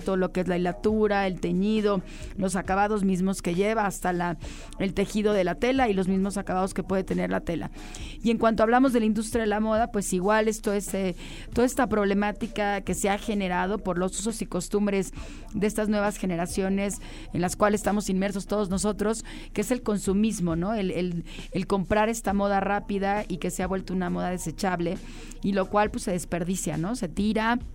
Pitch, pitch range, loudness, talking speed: 200 Hz, 185-210 Hz, -26 LUFS, 210 wpm